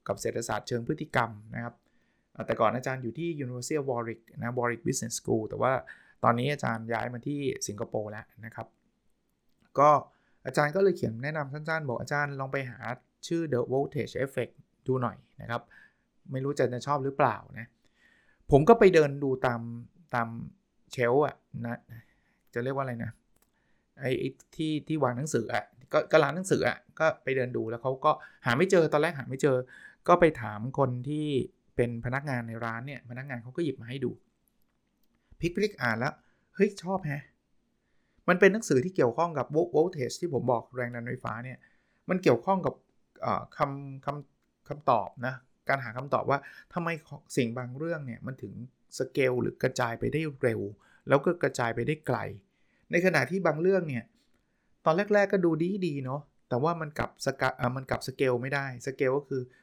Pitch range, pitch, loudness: 120-155 Hz, 135 Hz, -29 LUFS